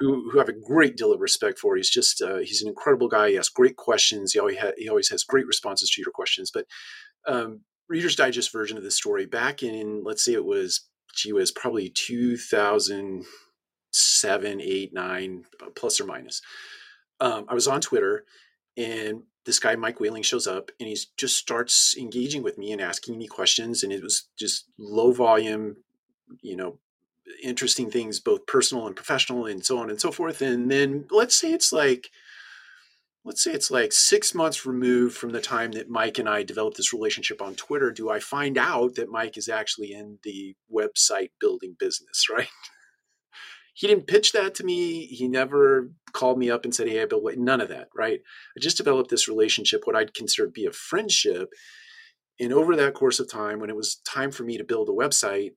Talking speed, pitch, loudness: 195 wpm, 370 Hz, -23 LUFS